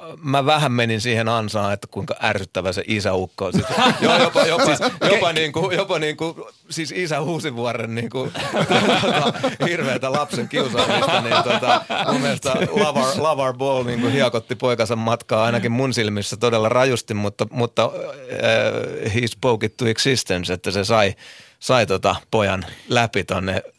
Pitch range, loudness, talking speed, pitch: 105-130 Hz, -20 LUFS, 140 wpm, 115 Hz